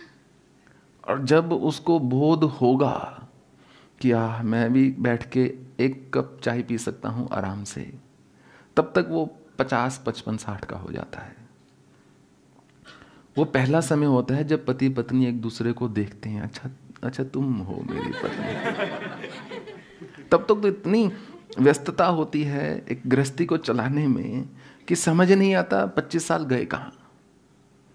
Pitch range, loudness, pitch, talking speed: 115-155 Hz, -24 LUFS, 130 Hz, 145 wpm